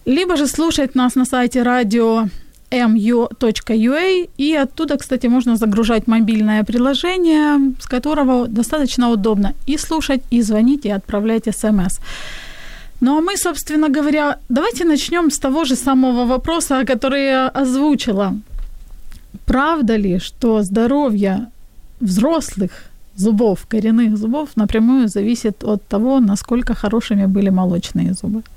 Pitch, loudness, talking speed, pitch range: 245 Hz, -16 LUFS, 120 wpm, 220-280 Hz